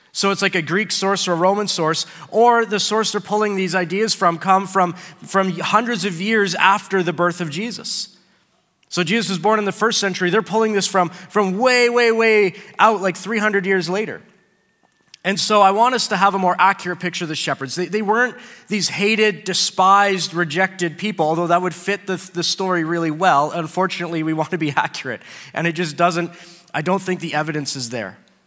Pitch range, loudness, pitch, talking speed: 175-210 Hz, -18 LUFS, 190 Hz, 205 wpm